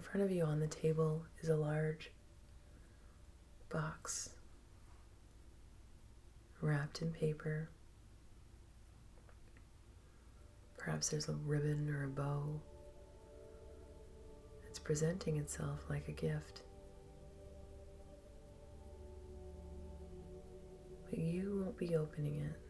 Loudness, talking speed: -41 LUFS, 85 wpm